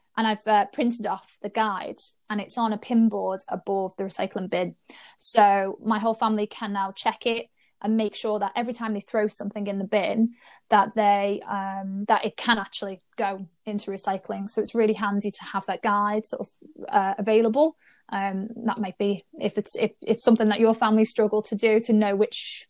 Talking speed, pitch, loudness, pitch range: 205 wpm, 210 Hz, -25 LUFS, 200-225 Hz